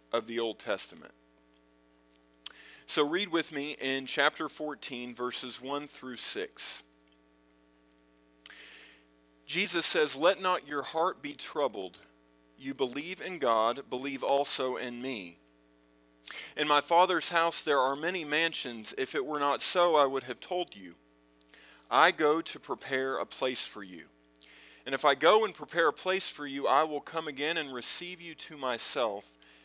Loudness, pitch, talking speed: -27 LUFS, 125 Hz, 155 wpm